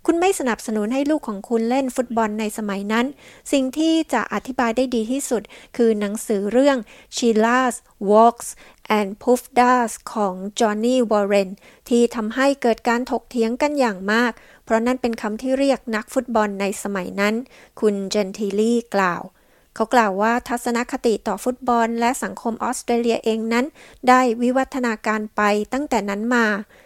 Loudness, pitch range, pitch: -20 LUFS, 215-255 Hz, 235 Hz